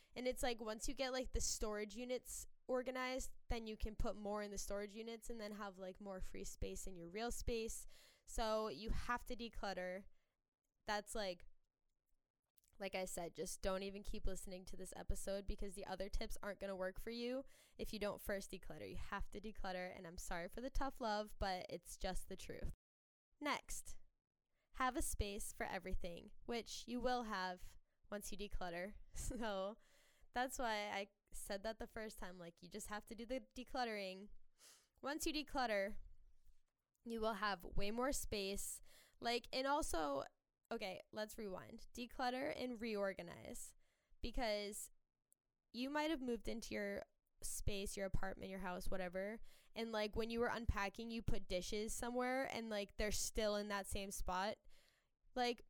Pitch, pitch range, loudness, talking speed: 210 Hz, 195-240 Hz, -46 LUFS, 170 wpm